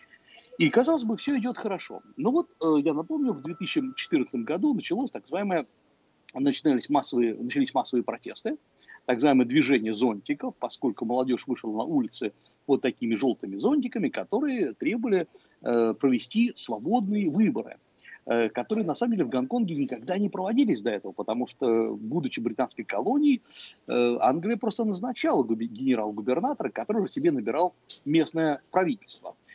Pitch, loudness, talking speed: 200 Hz, -27 LUFS, 130 wpm